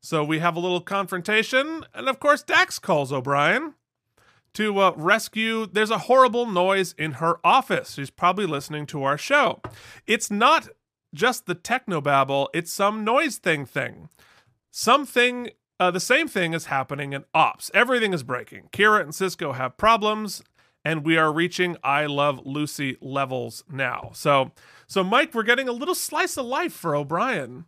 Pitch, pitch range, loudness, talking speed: 180 Hz, 145-230 Hz, -22 LUFS, 165 wpm